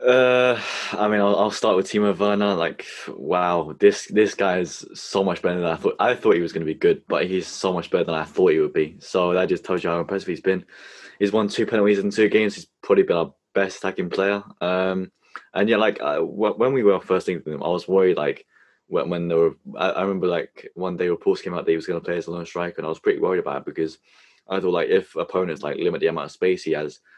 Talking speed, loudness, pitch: 275 wpm, -22 LUFS, 105 Hz